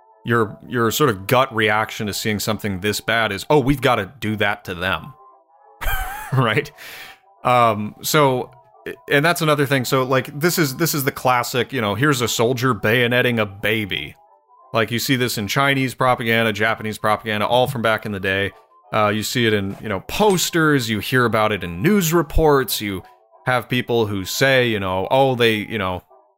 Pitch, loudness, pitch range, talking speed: 115 Hz, -19 LUFS, 105-130 Hz, 190 wpm